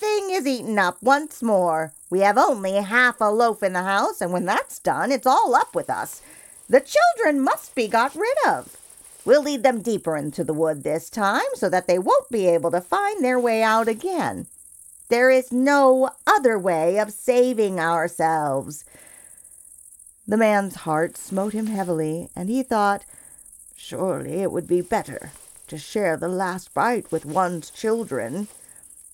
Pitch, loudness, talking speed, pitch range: 205 Hz, -21 LUFS, 170 wpm, 175-255 Hz